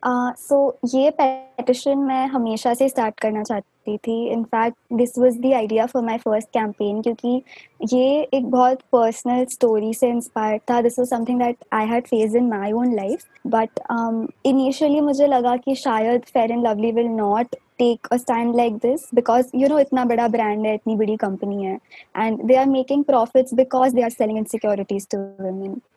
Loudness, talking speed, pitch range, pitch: -20 LUFS, 160 wpm, 225-255 Hz, 240 Hz